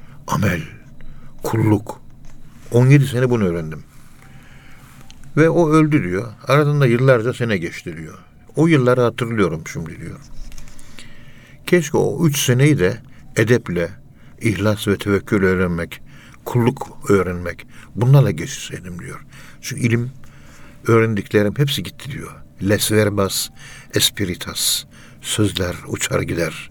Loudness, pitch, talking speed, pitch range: -18 LUFS, 120 Hz, 105 wpm, 105-135 Hz